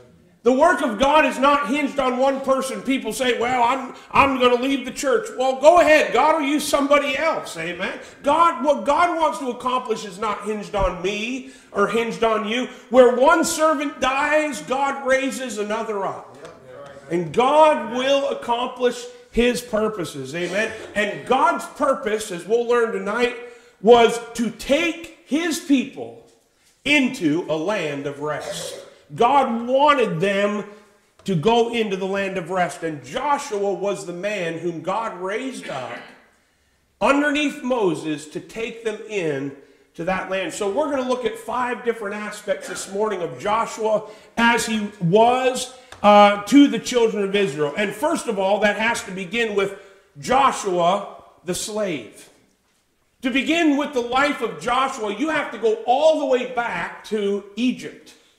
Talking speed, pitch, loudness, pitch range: 160 wpm, 235 Hz, -20 LUFS, 205-270 Hz